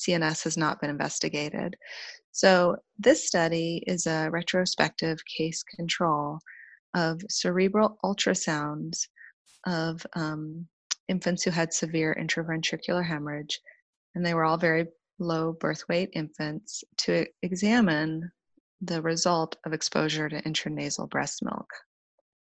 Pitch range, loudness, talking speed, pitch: 160-185 Hz, -28 LUFS, 115 wpm, 165 Hz